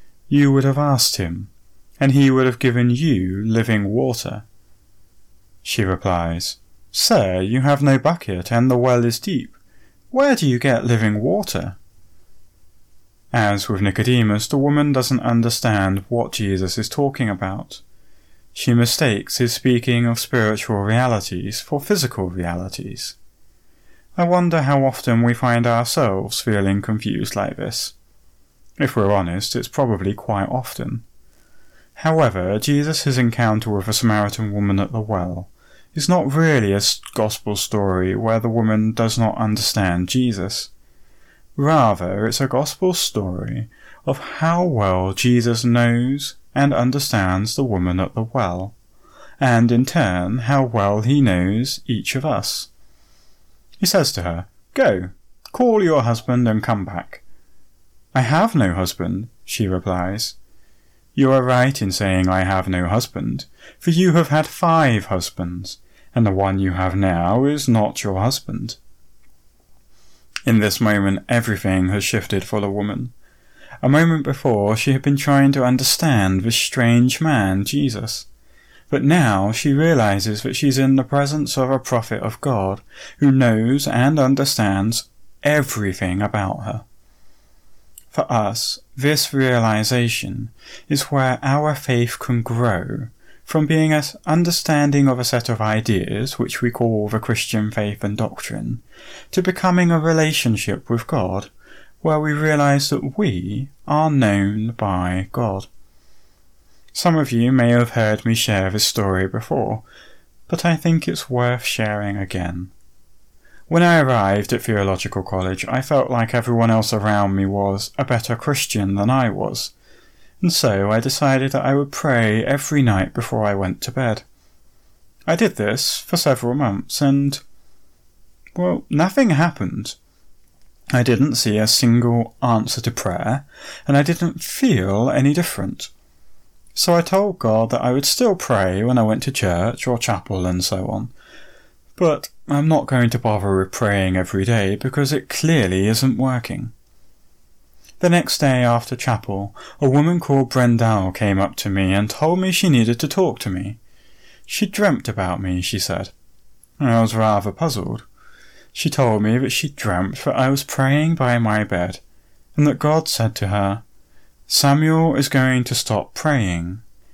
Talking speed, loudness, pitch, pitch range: 150 wpm, -19 LUFS, 115 Hz, 100-135 Hz